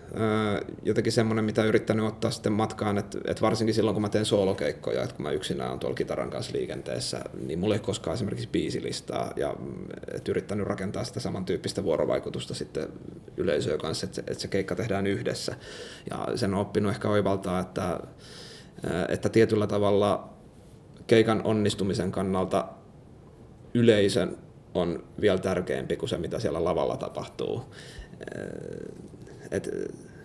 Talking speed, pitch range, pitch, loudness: 135 wpm, 95-110 Hz, 105 Hz, -28 LUFS